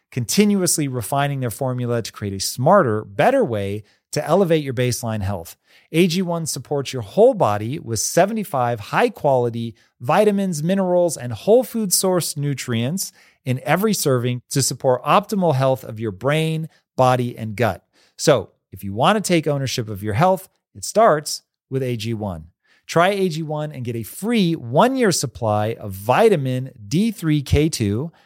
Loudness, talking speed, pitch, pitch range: -20 LUFS, 150 wpm, 135 Hz, 115-175 Hz